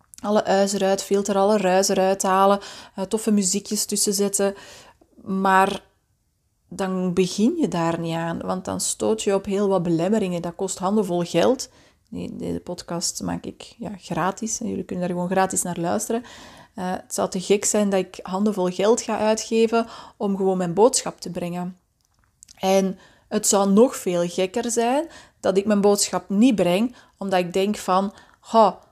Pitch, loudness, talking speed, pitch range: 195 Hz, -22 LUFS, 165 wpm, 180-215 Hz